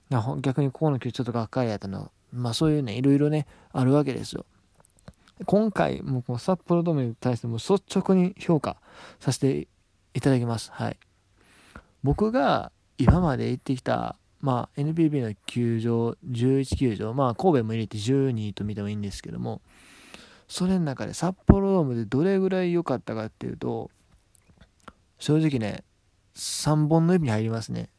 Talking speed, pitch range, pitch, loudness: 315 characters per minute, 110-155 Hz, 130 Hz, -26 LUFS